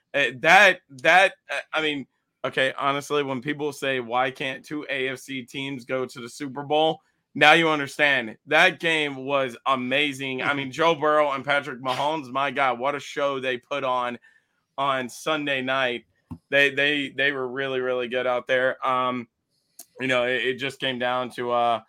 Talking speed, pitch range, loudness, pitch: 175 wpm, 130-145 Hz, -23 LUFS, 135 Hz